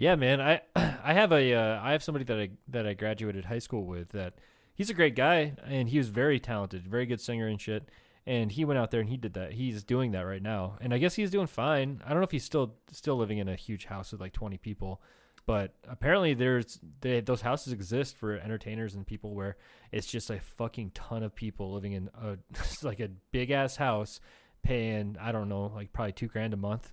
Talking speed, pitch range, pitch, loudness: 235 wpm, 105-130 Hz, 115 Hz, -32 LUFS